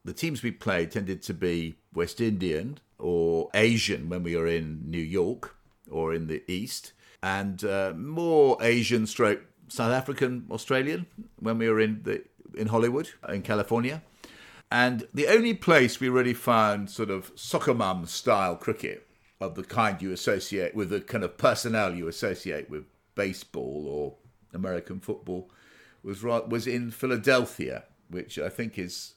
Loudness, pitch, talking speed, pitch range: -28 LUFS, 105 Hz, 155 wpm, 90-120 Hz